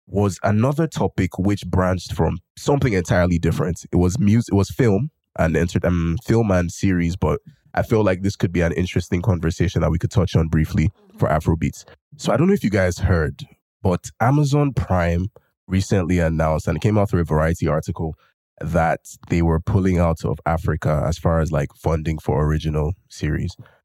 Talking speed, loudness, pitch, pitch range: 195 wpm, -21 LUFS, 90 Hz, 80-105 Hz